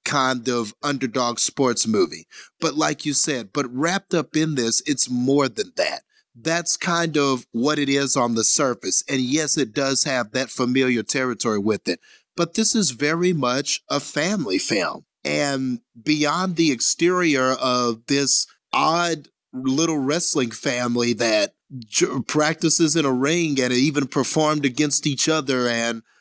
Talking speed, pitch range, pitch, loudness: 155 wpm, 125-160 Hz, 140 Hz, -21 LUFS